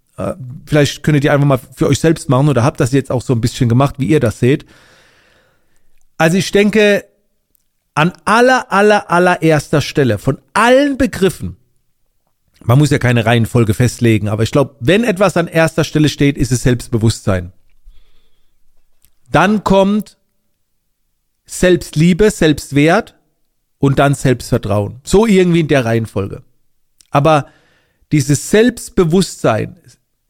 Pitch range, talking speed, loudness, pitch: 125-175 Hz, 130 wpm, -13 LUFS, 145 Hz